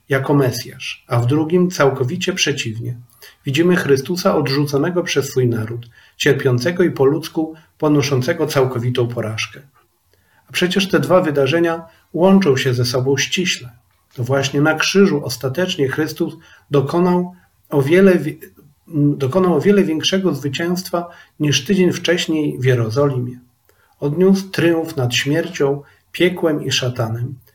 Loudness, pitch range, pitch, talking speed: -17 LUFS, 130-170 Hz, 145 Hz, 120 wpm